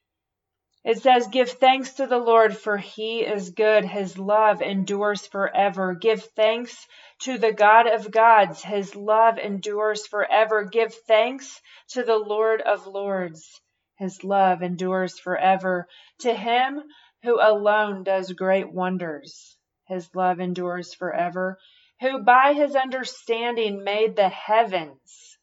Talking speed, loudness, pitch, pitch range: 130 wpm, -22 LUFS, 210 Hz, 185-230 Hz